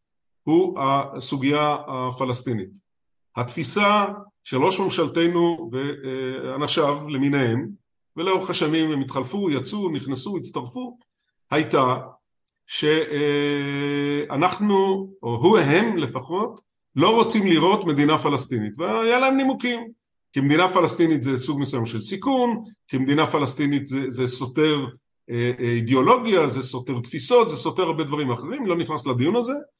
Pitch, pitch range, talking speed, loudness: 150 Hz, 135-190 Hz, 115 wpm, -22 LUFS